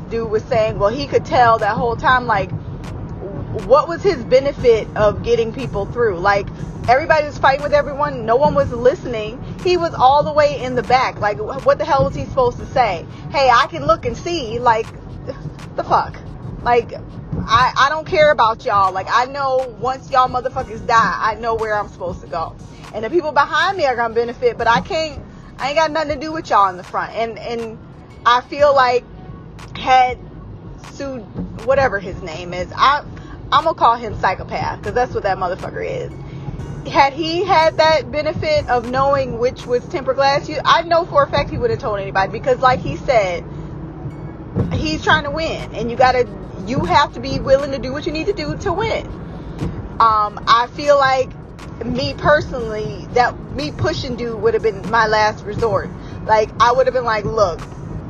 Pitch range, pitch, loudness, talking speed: 215-300 Hz, 255 Hz, -17 LUFS, 195 wpm